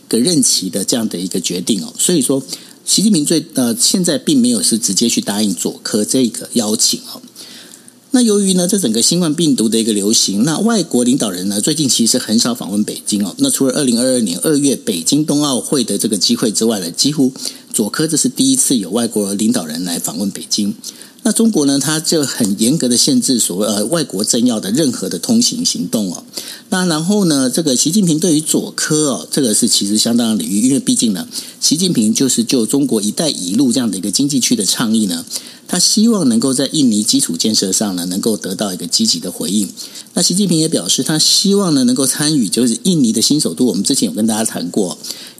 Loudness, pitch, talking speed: -14 LUFS, 215 Hz, 335 characters per minute